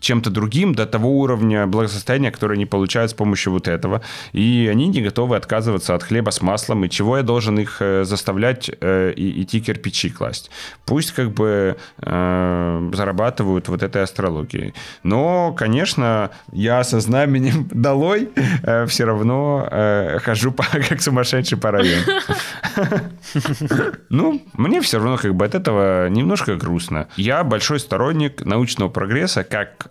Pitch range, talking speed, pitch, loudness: 100-135 Hz, 140 wpm, 110 Hz, -19 LUFS